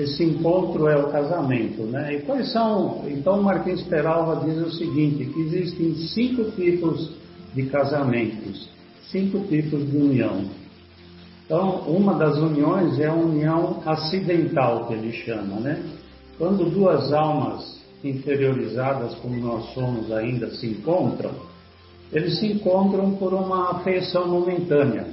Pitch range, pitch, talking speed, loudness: 130-180 Hz, 155 Hz, 130 wpm, -23 LUFS